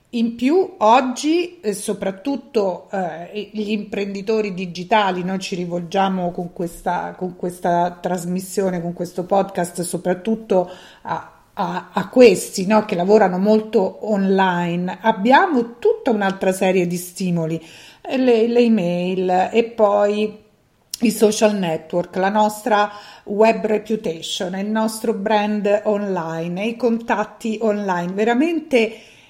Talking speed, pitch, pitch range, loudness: 115 wpm, 205 Hz, 180-220 Hz, -19 LUFS